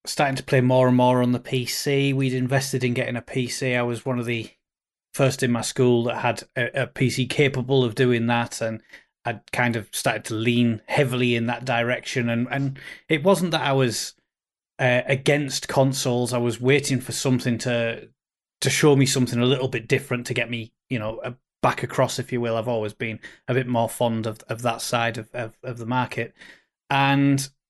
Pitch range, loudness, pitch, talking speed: 120-135 Hz, -23 LUFS, 125 Hz, 205 wpm